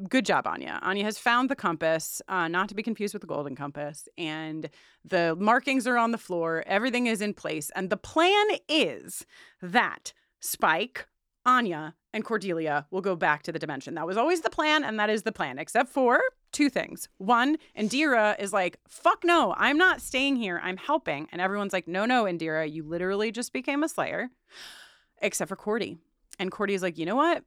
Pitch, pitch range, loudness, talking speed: 210 Hz, 175-260 Hz, -27 LUFS, 200 wpm